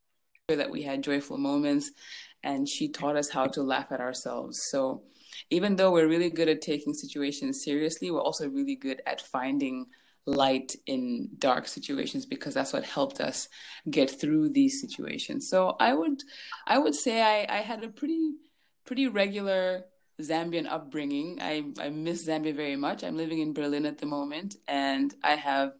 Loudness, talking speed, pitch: -29 LUFS, 170 wpm, 185 Hz